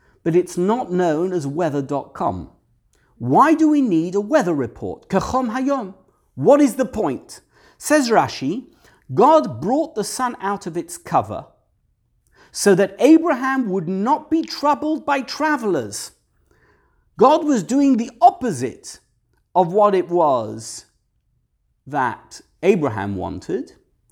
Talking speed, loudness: 125 wpm, -19 LUFS